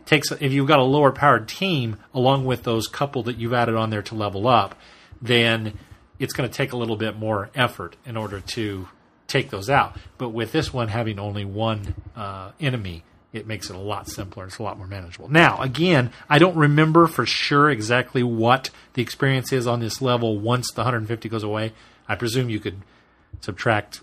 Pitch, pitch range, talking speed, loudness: 115 Hz, 105-130 Hz, 200 wpm, -21 LUFS